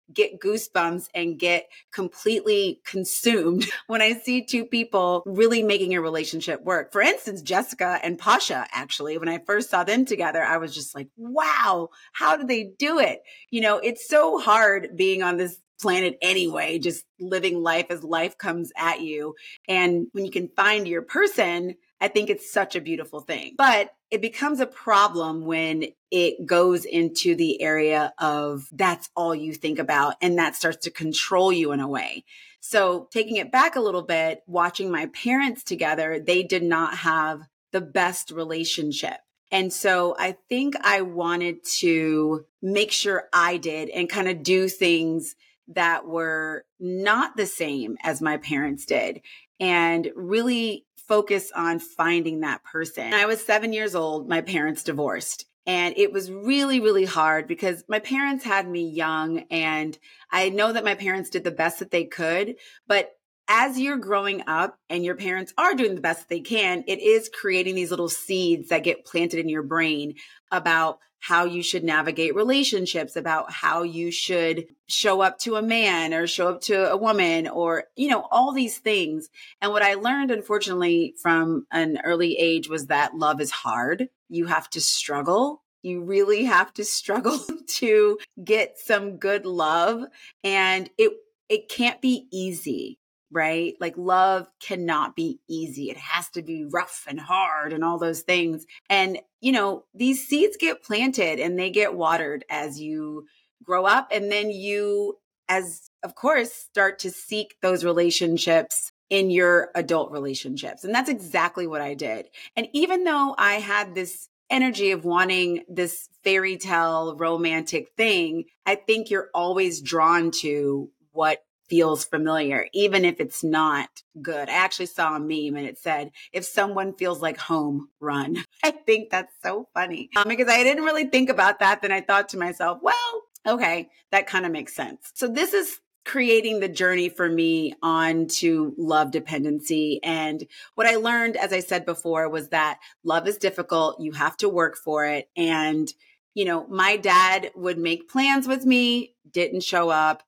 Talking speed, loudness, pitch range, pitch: 170 wpm, -23 LUFS, 165-215 Hz, 180 Hz